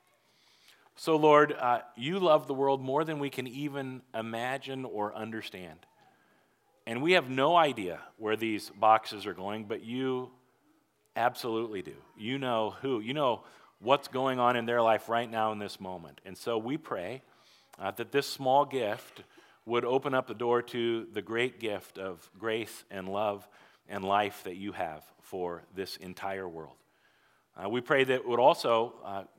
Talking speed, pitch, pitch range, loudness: 170 wpm, 115 Hz, 105-130 Hz, -31 LUFS